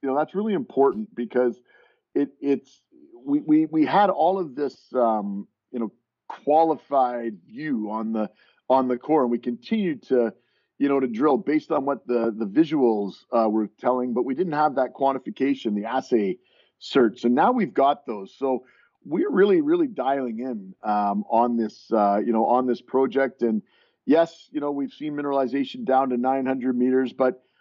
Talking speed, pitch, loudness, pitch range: 185 wpm, 130 Hz, -24 LUFS, 120-155 Hz